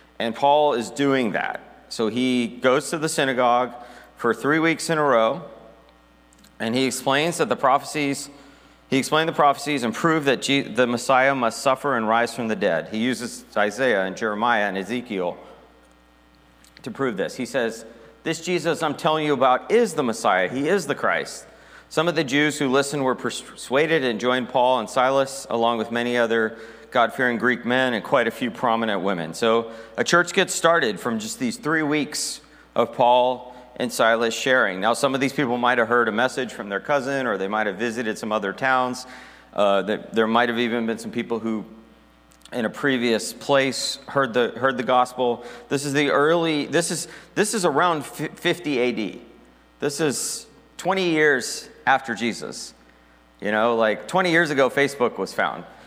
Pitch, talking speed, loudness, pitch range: 125 Hz, 185 wpm, -22 LUFS, 115-140 Hz